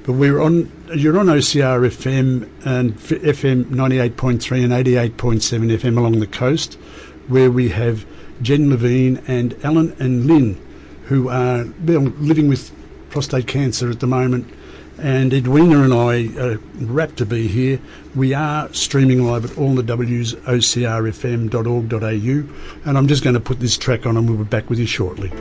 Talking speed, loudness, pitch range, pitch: 175 wpm, -17 LUFS, 120-140 Hz, 125 Hz